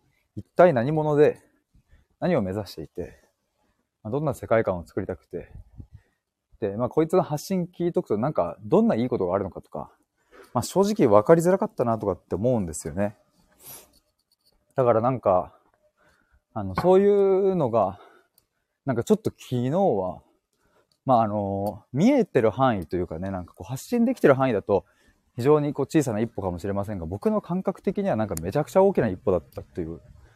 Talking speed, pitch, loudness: 360 characters per minute, 135 Hz, -24 LUFS